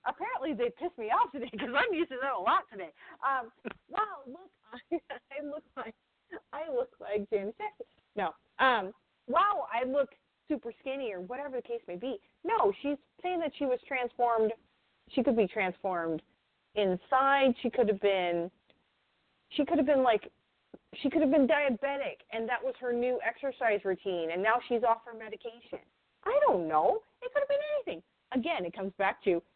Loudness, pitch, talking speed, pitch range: -31 LUFS, 250 Hz, 180 wpm, 220-290 Hz